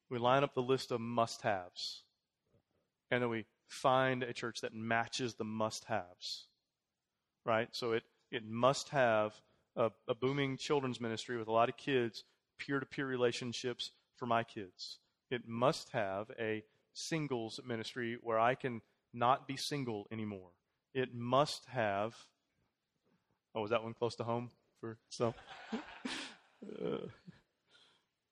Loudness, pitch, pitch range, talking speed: -37 LUFS, 120 Hz, 115-130 Hz, 145 wpm